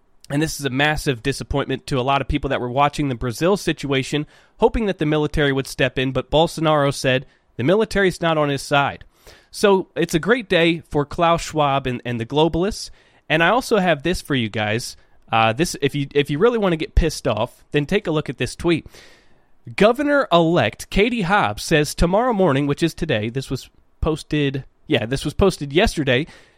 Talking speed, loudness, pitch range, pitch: 205 wpm, -20 LUFS, 135-170 Hz, 150 Hz